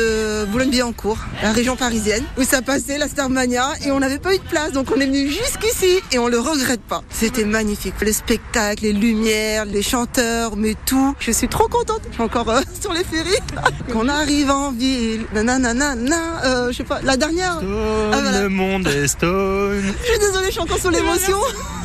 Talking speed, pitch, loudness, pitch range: 185 wpm, 255 Hz, -19 LUFS, 220-290 Hz